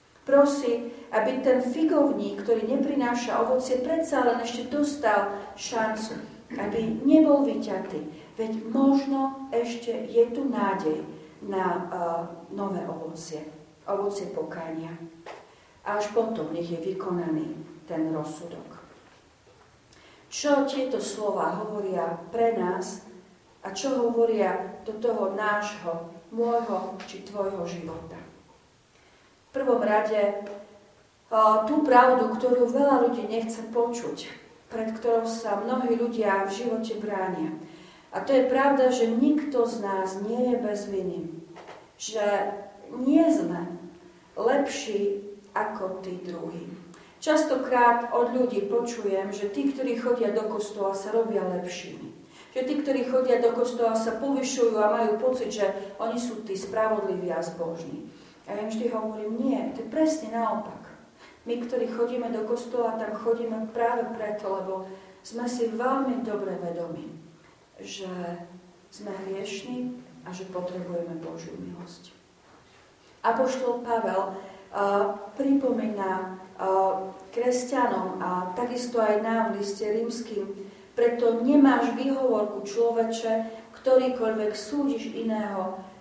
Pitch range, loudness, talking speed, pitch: 190-240 Hz, -27 LUFS, 120 wpm, 220 Hz